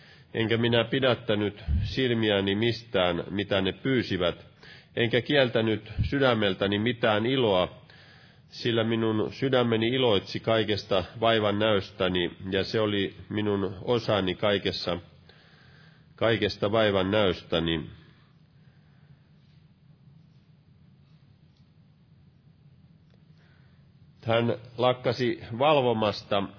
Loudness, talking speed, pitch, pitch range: -26 LUFS, 70 wpm, 115 Hz, 100-145 Hz